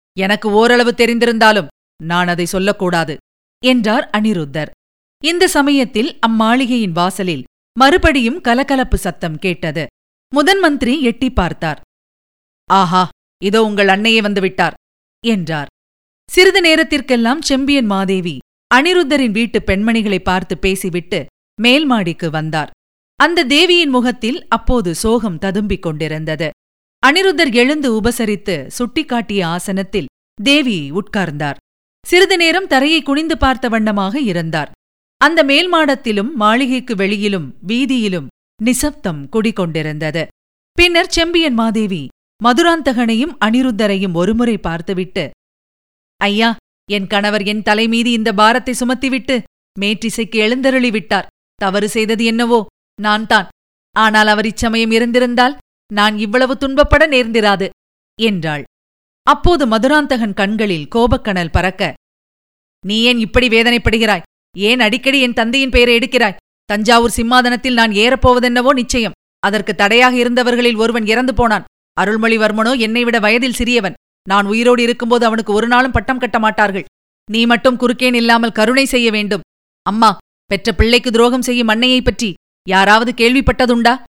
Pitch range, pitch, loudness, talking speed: 200-250 Hz, 230 Hz, -13 LUFS, 105 wpm